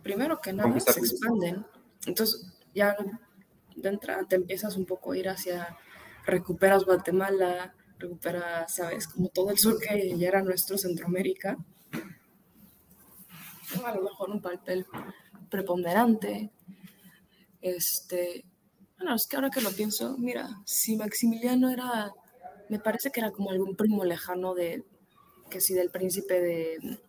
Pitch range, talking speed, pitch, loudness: 180-215 Hz, 135 wpm, 195 Hz, -29 LUFS